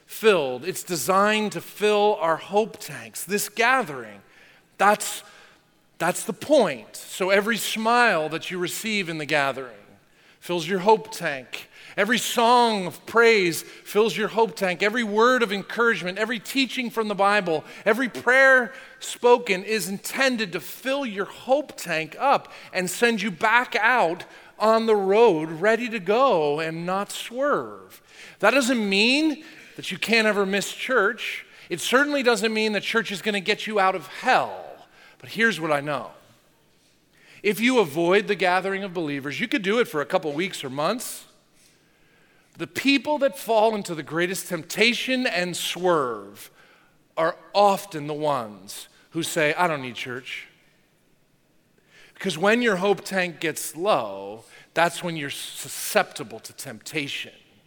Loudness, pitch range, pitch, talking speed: -23 LUFS, 175-230 Hz, 200 Hz, 155 wpm